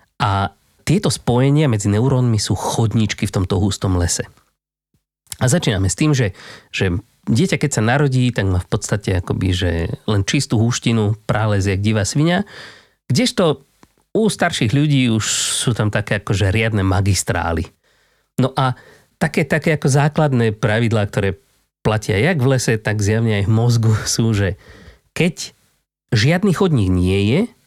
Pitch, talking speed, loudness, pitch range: 115 Hz, 150 wpm, -18 LUFS, 100-140 Hz